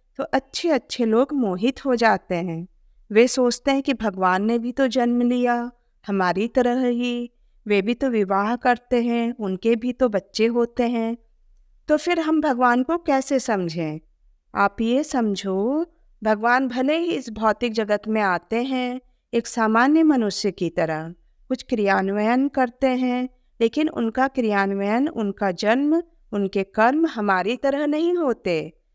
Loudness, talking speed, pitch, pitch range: -22 LUFS, 150 wpm, 240 Hz, 210-260 Hz